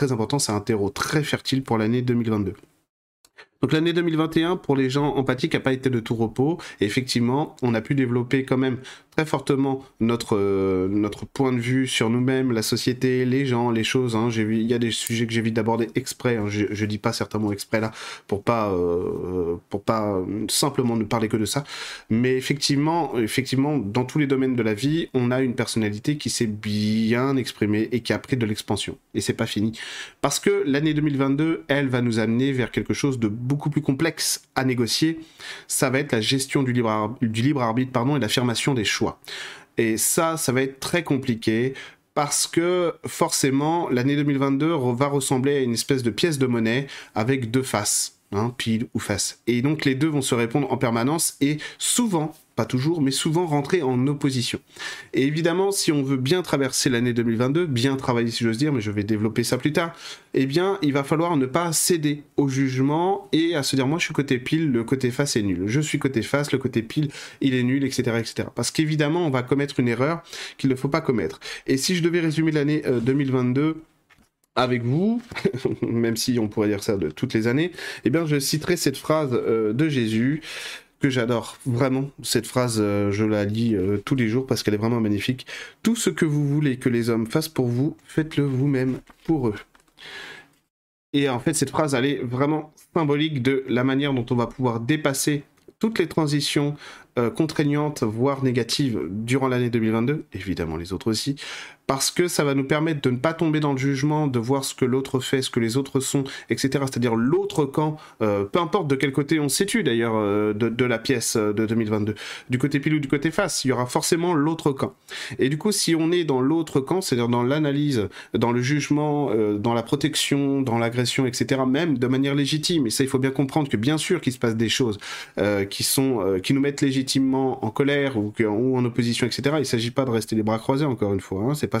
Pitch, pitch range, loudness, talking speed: 130 Hz, 115-145 Hz, -23 LUFS, 215 wpm